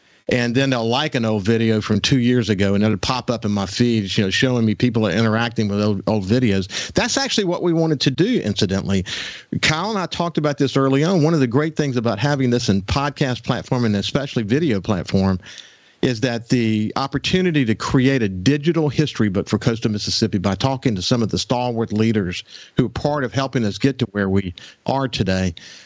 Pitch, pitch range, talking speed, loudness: 120 Hz, 105-135 Hz, 215 wpm, -19 LUFS